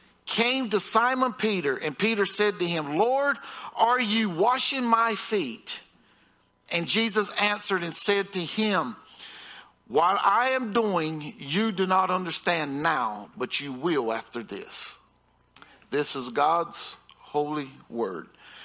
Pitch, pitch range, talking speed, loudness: 200 Hz, 155-225 Hz, 130 wpm, -26 LUFS